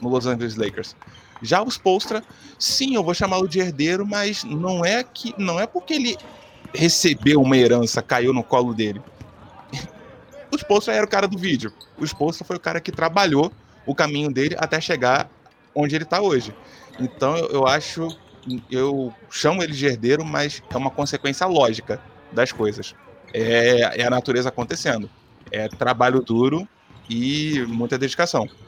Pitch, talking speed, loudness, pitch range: 145 Hz, 165 wpm, -21 LUFS, 125-180 Hz